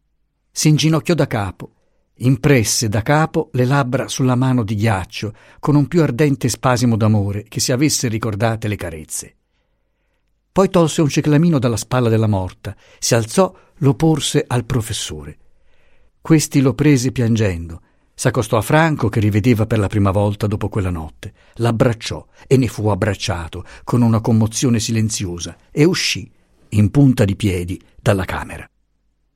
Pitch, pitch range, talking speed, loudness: 115 Hz, 105-140 Hz, 145 wpm, -17 LUFS